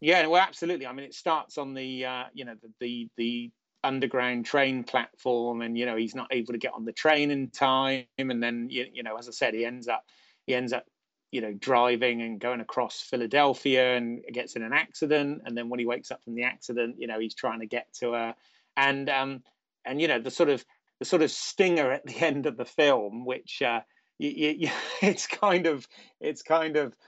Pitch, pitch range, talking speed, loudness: 125 Hz, 120-140 Hz, 220 wpm, -28 LUFS